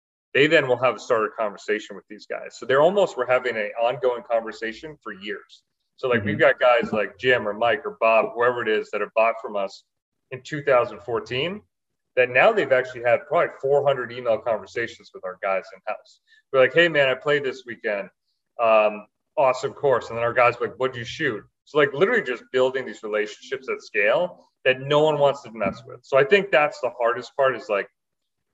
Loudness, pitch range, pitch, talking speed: -22 LUFS, 115-145 Hz, 125 Hz, 210 wpm